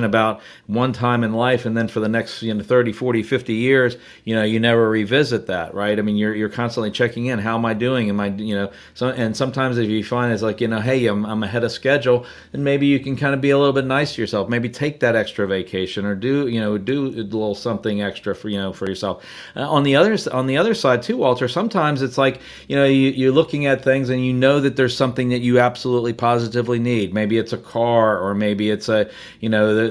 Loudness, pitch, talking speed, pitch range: -19 LUFS, 120 Hz, 255 wpm, 110-130 Hz